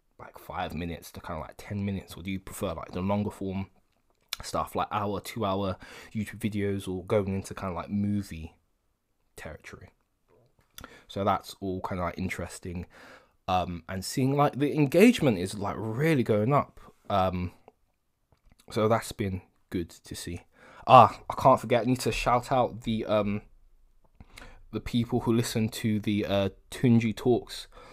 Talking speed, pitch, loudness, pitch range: 165 wpm, 100 Hz, -28 LUFS, 95-115 Hz